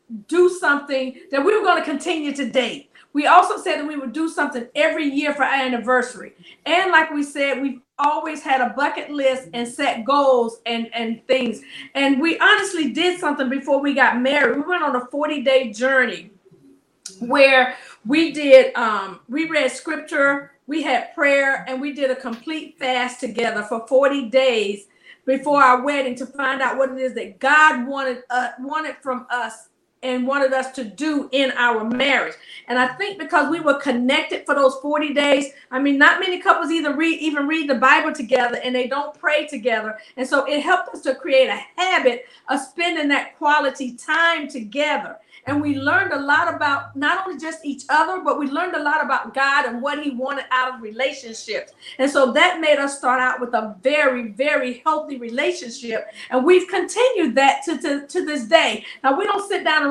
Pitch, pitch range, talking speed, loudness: 280 Hz, 255-310 Hz, 195 wpm, -19 LUFS